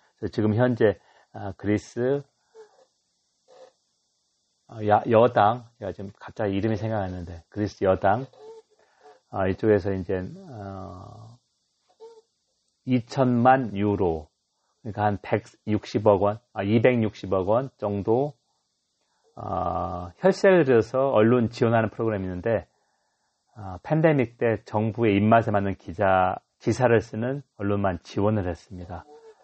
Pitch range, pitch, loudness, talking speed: 100-125 Hz, 110 Hz, -24 LUFS, 205 characters per minute